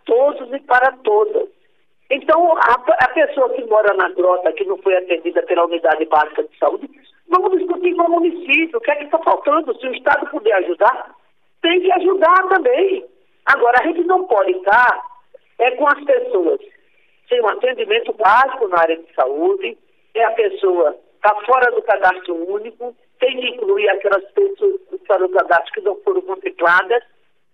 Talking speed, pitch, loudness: 175 wpm, 330 Hz, -16 LUFS